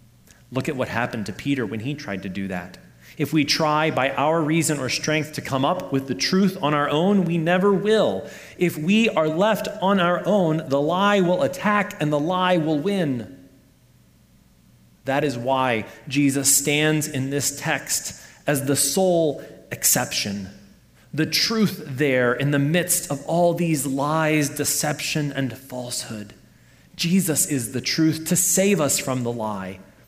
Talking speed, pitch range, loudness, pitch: 165 wpm, 130-170 Hz, -21 LUFS, 145 Hz